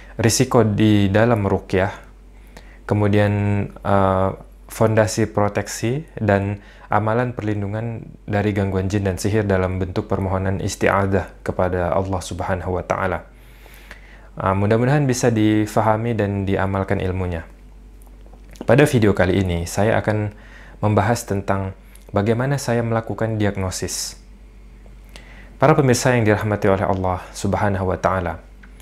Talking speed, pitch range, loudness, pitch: 110 wpm, 95-110 Hz, -20 LUFS, 100 Hz